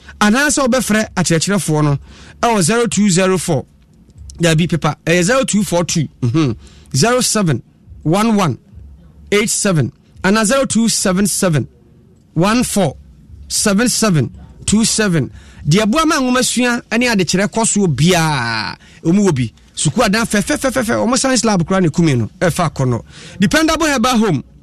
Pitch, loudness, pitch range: 190 Hz, -15 LUFS, 160-225 Hz